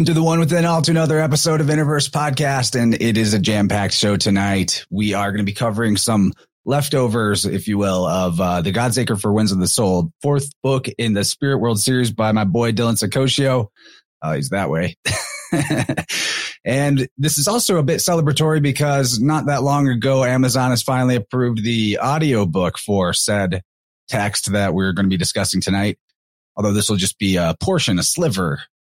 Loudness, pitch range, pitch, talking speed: -18 LUFS, 100-140 Hz, 120 Hz, 190 wpm